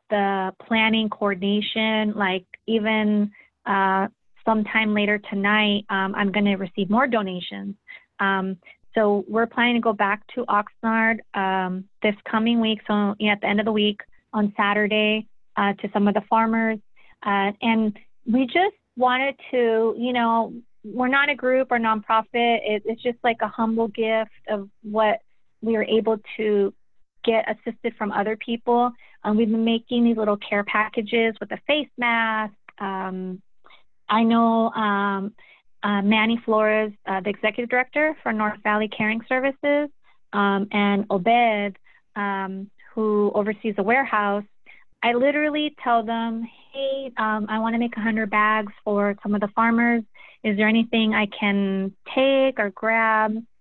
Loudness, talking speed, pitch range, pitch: -22 LUFS, 155 wpm, 205-230 Hz, 220 Hz